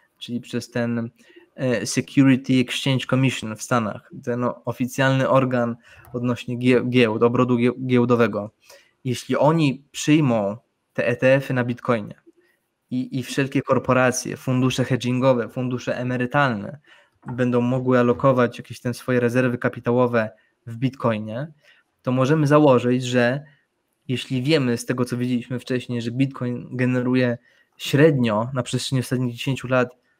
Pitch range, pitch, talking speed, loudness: 120-130 Hz, 125 Hz, 120 wpm, -21 LUFS